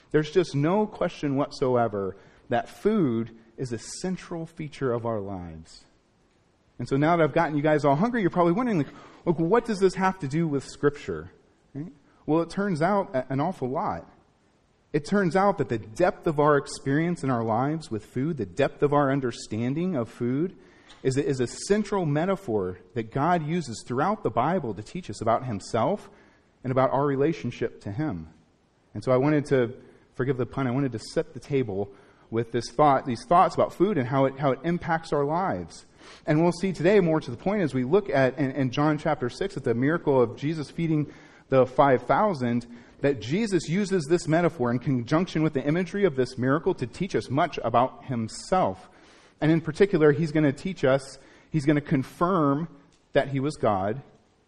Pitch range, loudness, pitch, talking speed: 125-165 Hz, -26 LUFS, 140 Hz, 195 wpm